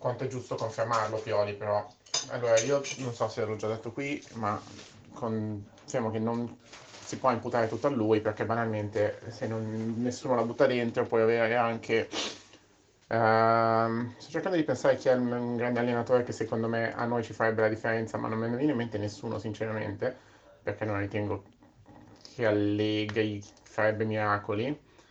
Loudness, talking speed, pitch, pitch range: -30 LUFS, 170 wpm, 115 Hz, 110-120 Hz